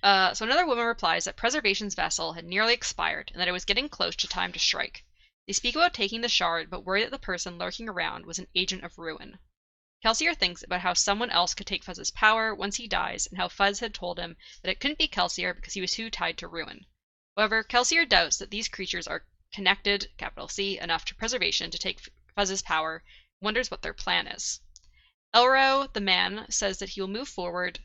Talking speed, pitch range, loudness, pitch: 220 wpm, 180-230 Hz, -27 LUFS, 200 Hz